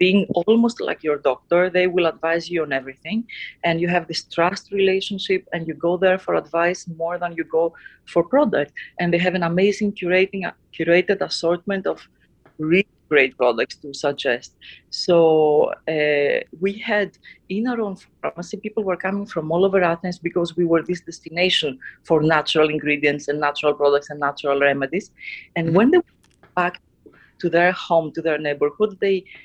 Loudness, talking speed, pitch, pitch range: -21 LUFS, 170 wpm, 175 Hz, 160-190 Hz